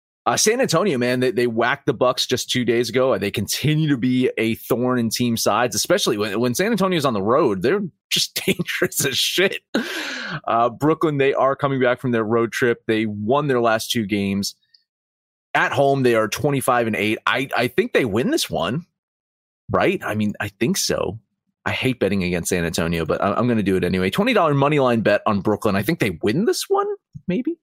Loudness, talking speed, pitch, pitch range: -20 LUFS, 215 wpm, 120 Hz, 105-140 Hz